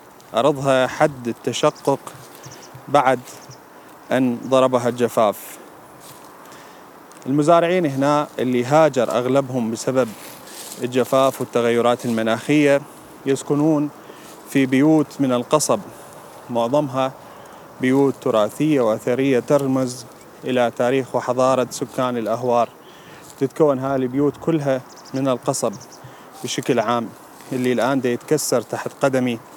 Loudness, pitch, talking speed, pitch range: -20 LUFS, 130 Hz, 90 wpm, 125-140 Hz